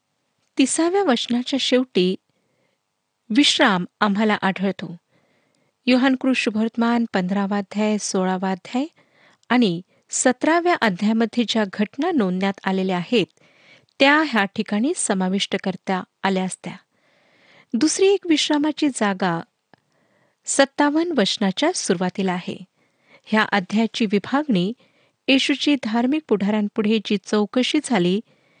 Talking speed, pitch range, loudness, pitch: 90 wpm, 195-265 Hz, -20 LUFS, 220 Hz